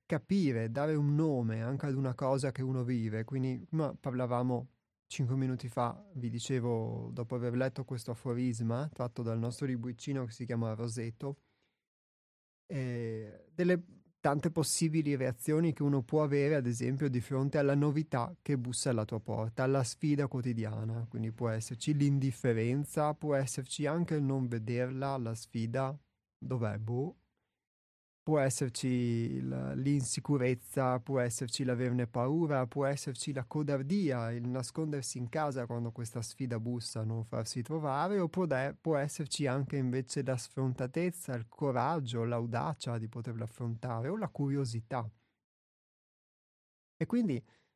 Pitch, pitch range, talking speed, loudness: 130 Hz, 120-145 Hz, 140 wpm, -34 LUFS